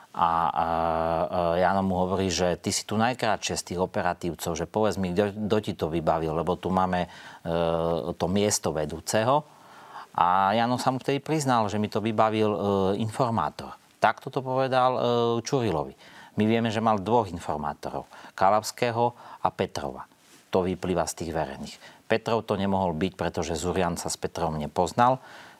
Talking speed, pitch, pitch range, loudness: 160 wpm, 95 Hz, 85-115 Hz, -26 LUFS